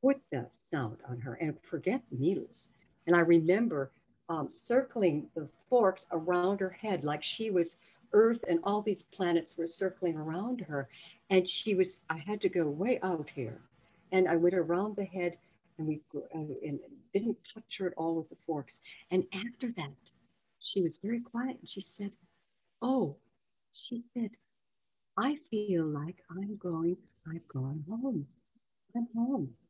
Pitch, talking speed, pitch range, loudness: 180 Hz, 165 wpm, 165-215 Hz, -33 LUFS